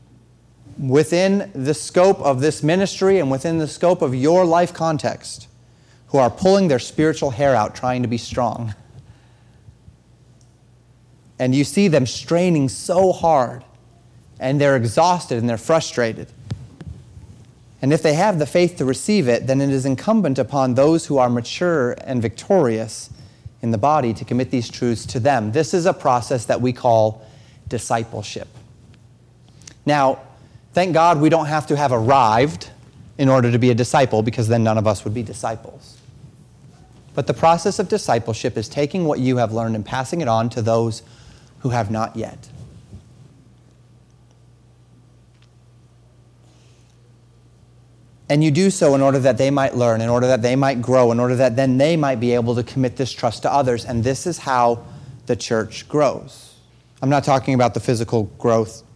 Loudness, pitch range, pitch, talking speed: -18 LUFS, 120-140 Hz, 125 Hz, 165 wpm